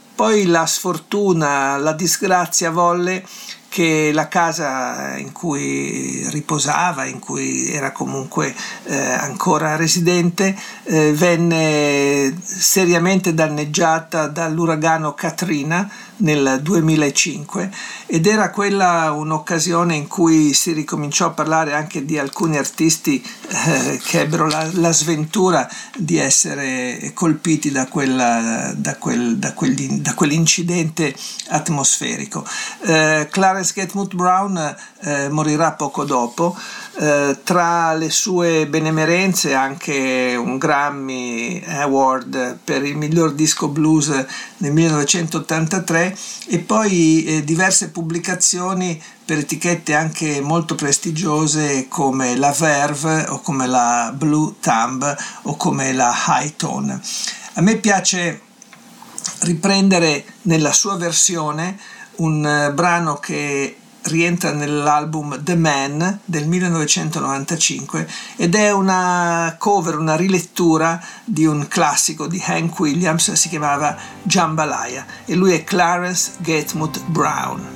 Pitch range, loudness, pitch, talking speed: 150-180 Hz, -17 LUFS, 165 Hz, 110 wpm